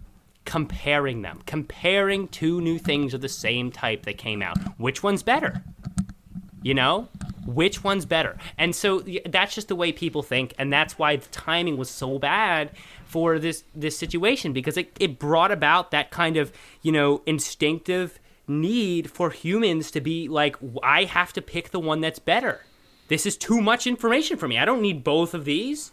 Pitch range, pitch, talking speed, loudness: 150-185 Hz, 160 Hz, 185 wpm, -24 LUFS